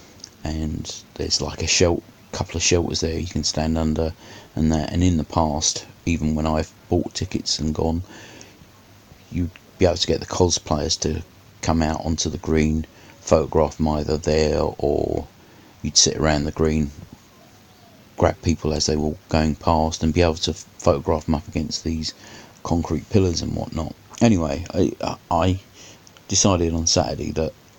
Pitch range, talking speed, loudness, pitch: 80-95 Hz, 165 wpm, -22 LUFS, 80 Hz